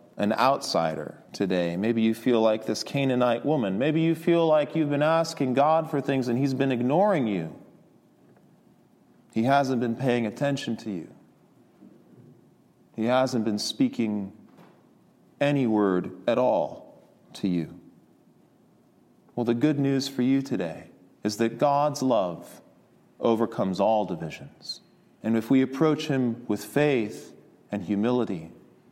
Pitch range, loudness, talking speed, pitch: 110-140 Hz, -25 LUFS, 135 wpm, 125 Hz